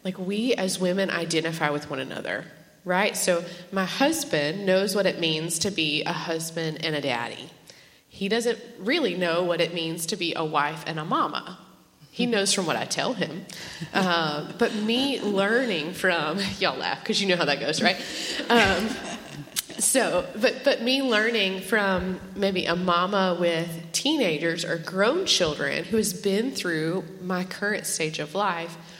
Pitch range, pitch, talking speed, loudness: 165-200 Hz, 180 Hz, 170 wpm, -25 LUFS